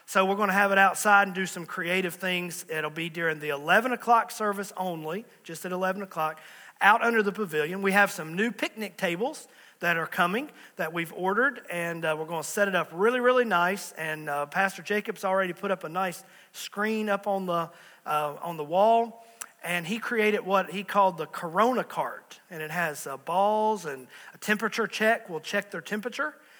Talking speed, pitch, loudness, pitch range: 205 wpm, 190 Hz, -27 LUFS, 170-210 Hz